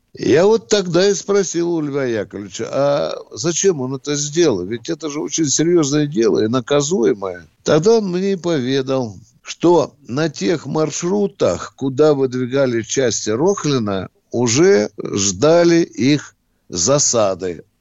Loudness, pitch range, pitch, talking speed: -17 LUFS, 125-170 Hz, 145 Hz, 130 wpm